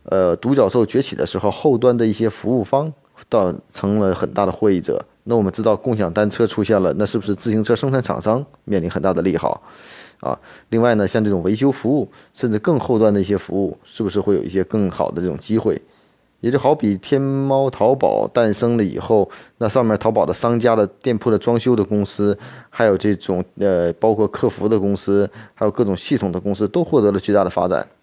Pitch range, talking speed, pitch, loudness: 100-120 Hz, 325 characters per minute, 105 Hz, -18 LUFS